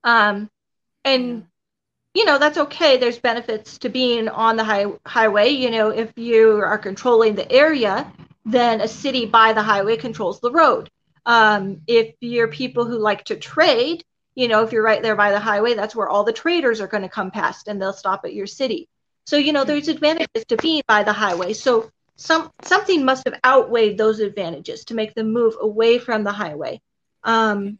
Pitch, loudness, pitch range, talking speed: 230 Hz, -18 LUFS, 215-260 Hz, 195 wpm